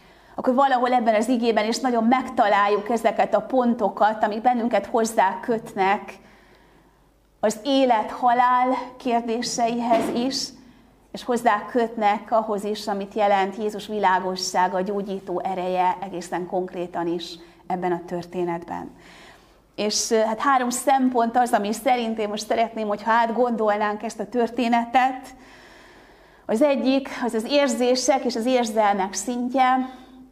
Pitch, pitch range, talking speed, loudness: 225 Hz, 200-250 Hz, 125 wpm, -22 LUFS